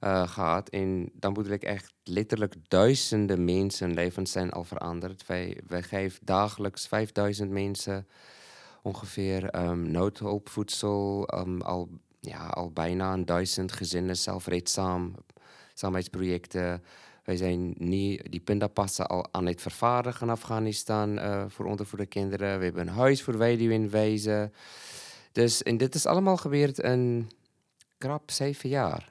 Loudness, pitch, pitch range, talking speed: -29 LUFS, 100 Hz, 90-110 Hz, 140 wpm